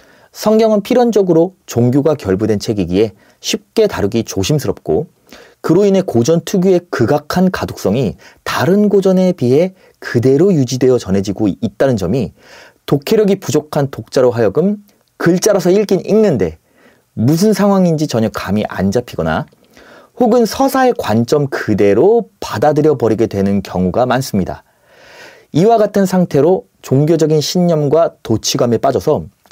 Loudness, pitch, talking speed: -14 LUFS, 155 Hz, 305 characters per minute